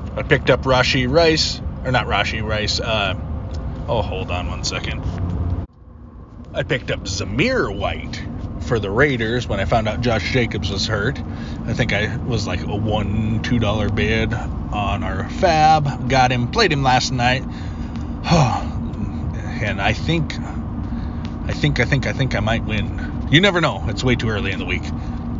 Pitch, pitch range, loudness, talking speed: 110 Hz, 95-125 Hz, -20 LUFS, 170 wpm